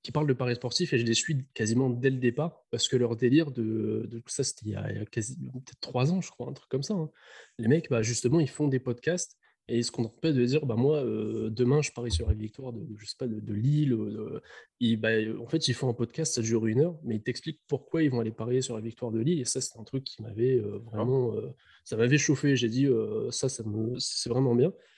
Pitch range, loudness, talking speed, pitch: 115-140 Hz, -29 LUFS, 270 wpm, 125 Hz